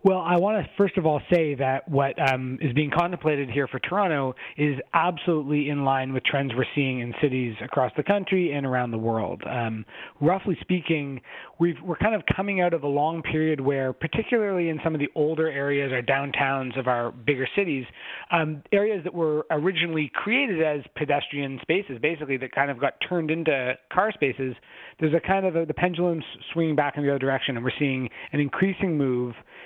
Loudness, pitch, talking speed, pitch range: -25 LUFS, 150 Hz, 200 wpm, 135-170 Hz